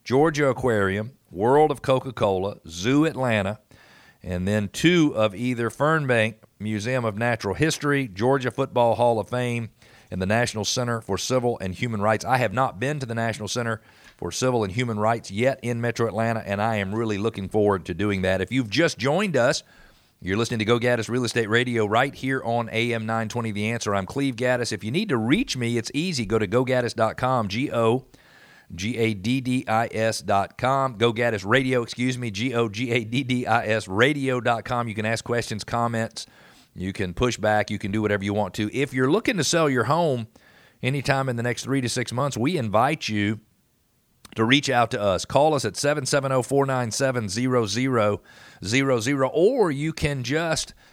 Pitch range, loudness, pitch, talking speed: 110-130 Hz, -23 LUFS, 120 Hz, 180 wpm